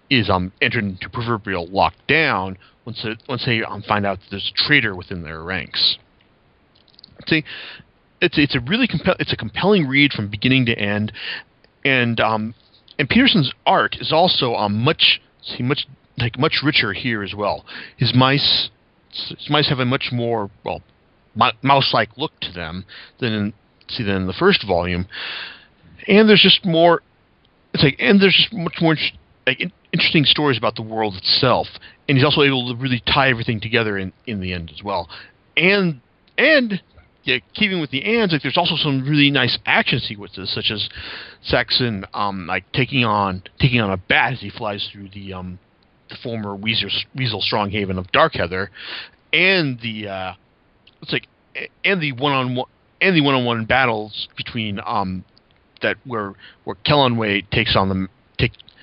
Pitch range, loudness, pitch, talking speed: 100-140 Hz, -18 LUFS, 115 Hz, 175 wpm